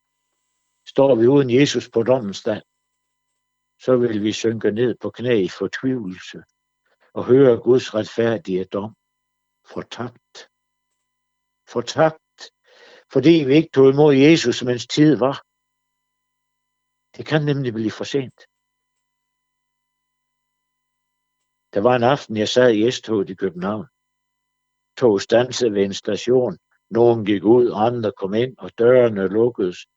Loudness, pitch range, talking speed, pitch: -18 LUFS, 120-145 Hz, 130 wpm, 145 Hz